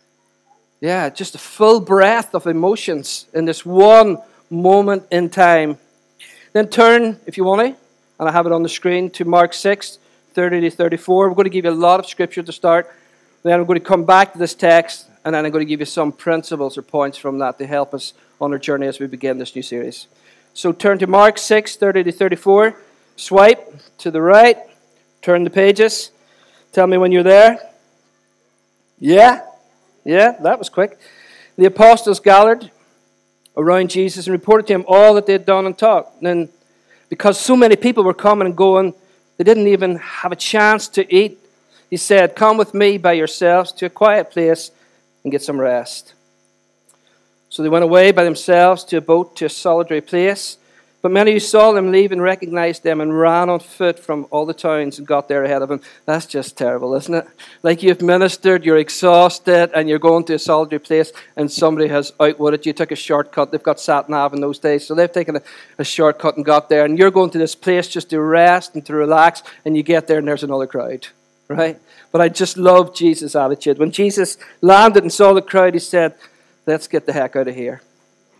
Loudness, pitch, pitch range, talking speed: -14 LUFS, 175 Hz, 155-195 Hz, 205 wpm